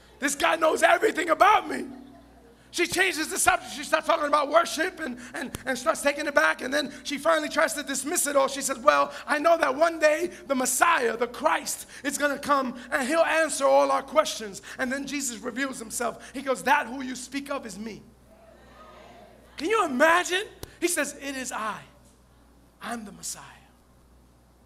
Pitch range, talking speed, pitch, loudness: 260-315 Hz, 190 wpm, 285 Hz, -25 LUFS